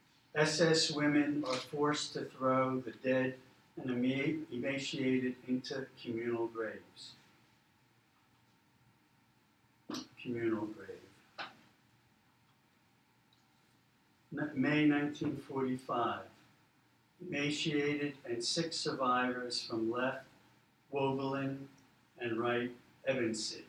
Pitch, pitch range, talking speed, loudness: 130 Hz, 120-145 Hz, 70 wpm, -35 LUFS